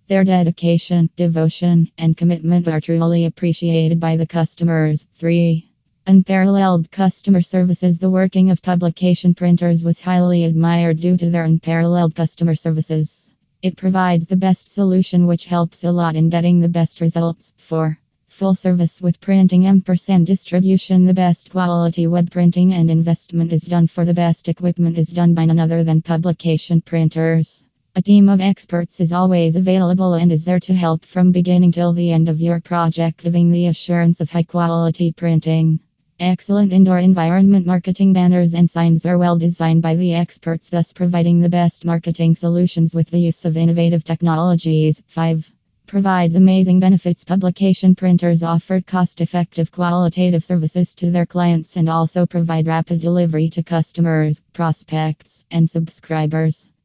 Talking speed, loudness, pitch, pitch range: 155 wpm, -16 LUFS, 170 Hz, 165-180 Hz